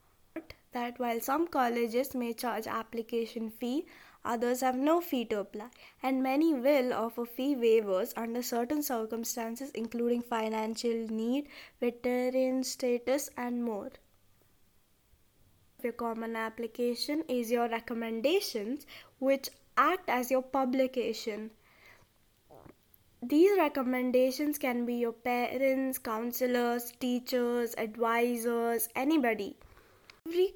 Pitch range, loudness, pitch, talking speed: 230-265 Hz, -32 LUFS, 240 Hz, 100 wpm